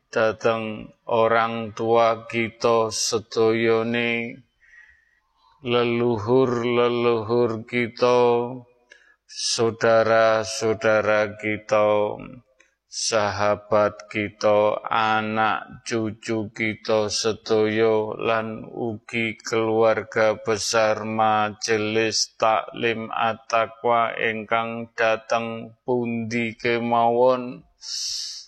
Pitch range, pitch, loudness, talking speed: 110-120 Hz, 115 Hz, -22 LUFS, 60 wpm